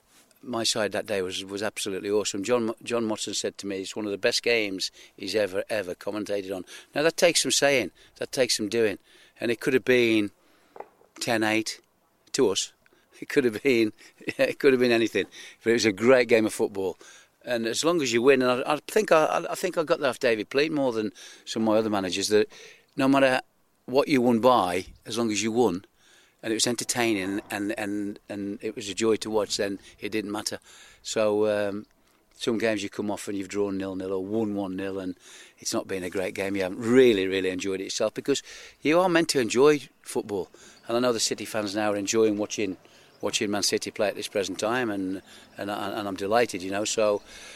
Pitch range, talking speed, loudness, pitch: 100-120 Hz, 225 wpm, -26 LUFS, 110 Hz